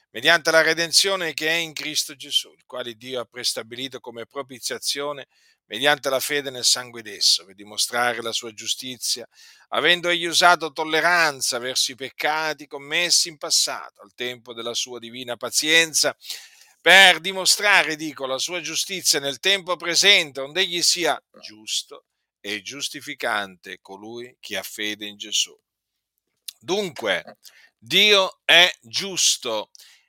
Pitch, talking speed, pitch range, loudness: 145 Hz, 130 wpm, 120-170 Hz, -20 LUFS